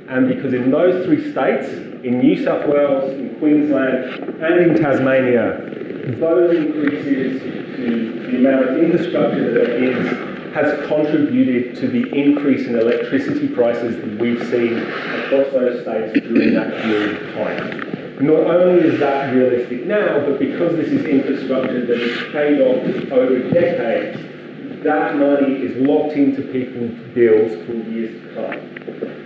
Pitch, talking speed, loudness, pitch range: 135 Hz, 150 wpm, -17 LUFS, 120-150 Hz